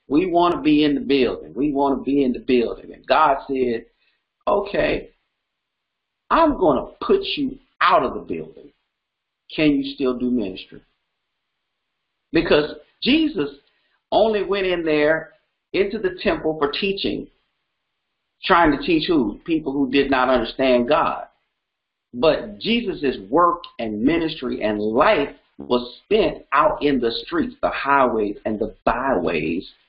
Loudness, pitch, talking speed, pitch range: -20 LUFS, 150 Hz, 145 wpm, 130-200 Hz